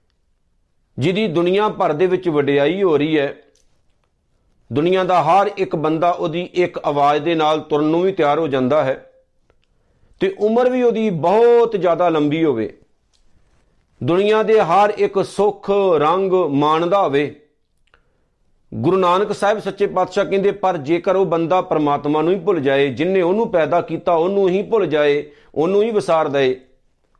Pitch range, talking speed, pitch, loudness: 150-200 Hz, 150 wpm, 175 Hz, -17 LUFS